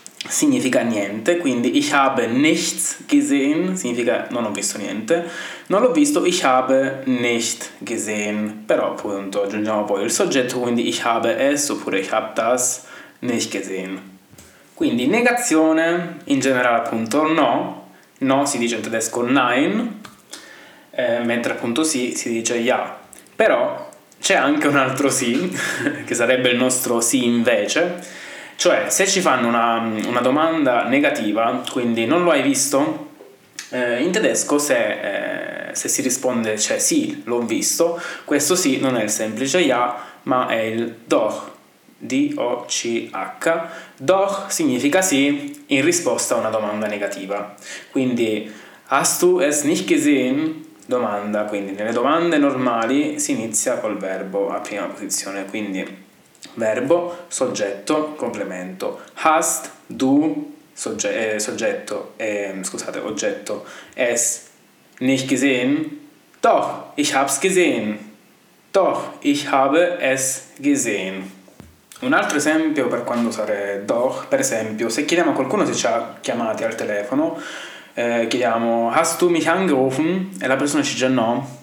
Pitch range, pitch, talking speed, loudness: 115-190 Hz, 135 Hz, 135 wpm, -19 LUFS